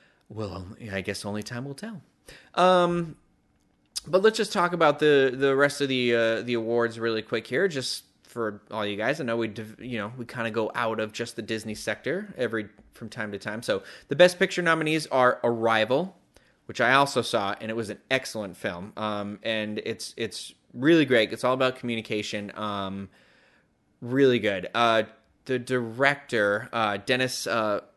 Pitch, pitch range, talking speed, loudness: 115 Hz, 110-135 Hz, 180 wpm, -26 LUFS